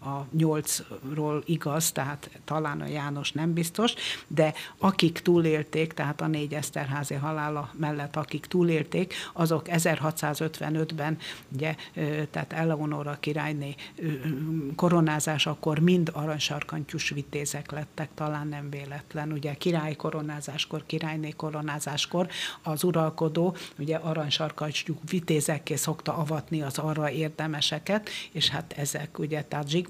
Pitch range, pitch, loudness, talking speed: 150-160 Hz, 155 Hz, -29 LUFS, 110 wpm